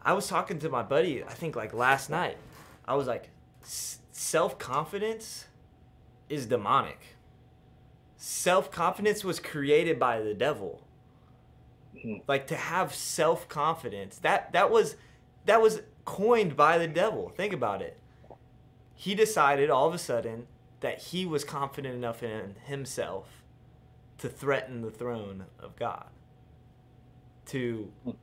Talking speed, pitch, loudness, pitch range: 125 wpm, 130 Hz, -29 LUFS, 120-165 Hz